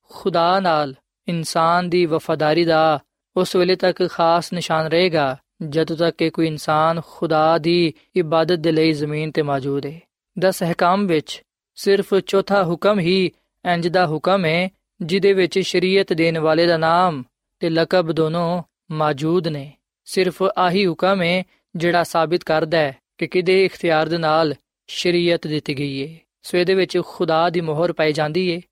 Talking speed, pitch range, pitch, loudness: 140 wpm, 160-180 Hz, 170 Hz, -19 LUFS